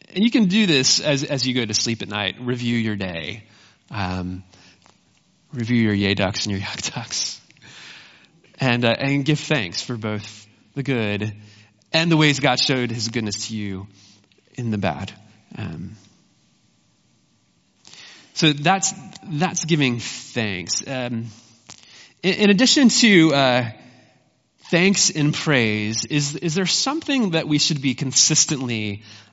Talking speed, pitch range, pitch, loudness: 145 wpm, 105-155 Hz, 125 Hz, -20 LUFS